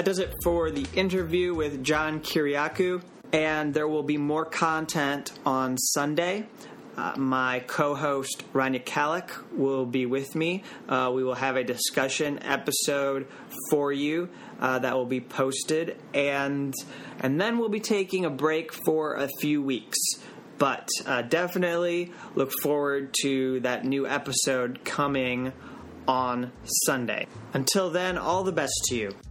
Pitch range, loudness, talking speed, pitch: 130-165 Hz, -27 LUFS, 145 wpm, 145 Hz